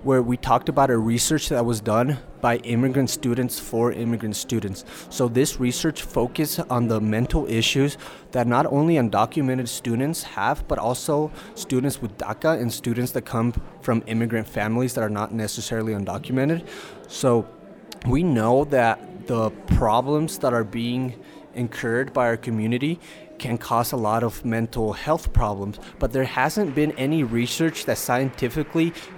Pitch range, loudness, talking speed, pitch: 115-140 Hz, -23 LUFS, 155 wpm, 125 Hz